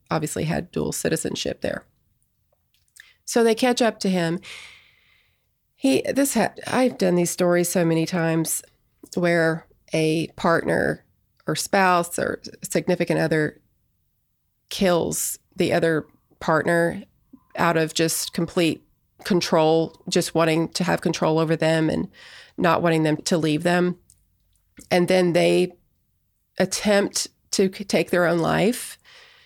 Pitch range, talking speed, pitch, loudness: 160-185 Hz, 125 wpm, 175 Hz, -22 LUFS